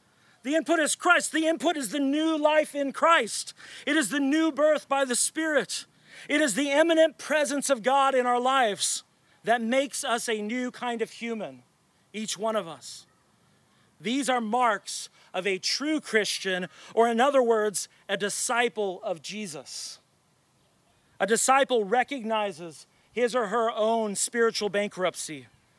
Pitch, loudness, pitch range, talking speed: 245 Hz, -26 LUFS, 210-280 Hz, 155 wpm